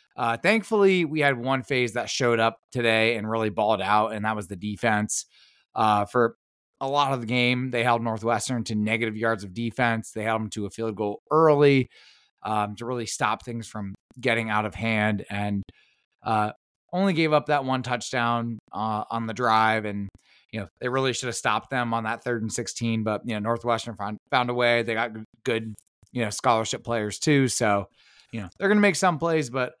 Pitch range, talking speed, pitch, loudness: 110-125 Hz, 205 wpm, 115 Hz, -25 LUFS